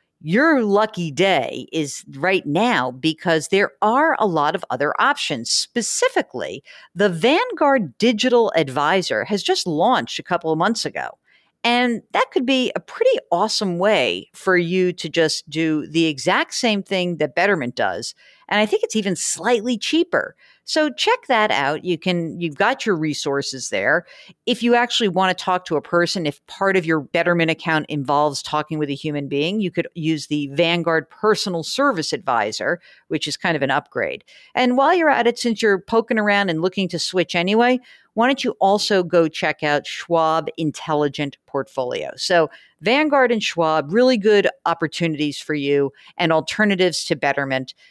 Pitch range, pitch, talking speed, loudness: 155-225 Hz, 180 Hz, 170 wpm, -20 LUFS